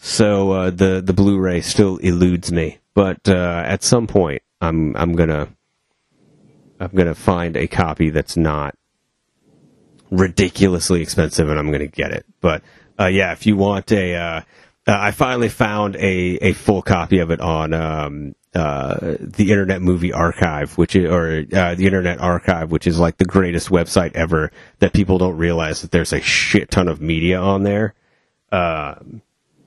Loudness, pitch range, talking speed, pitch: -18 LUFS, 85-100 Hz, 170 wpm, 90 Hz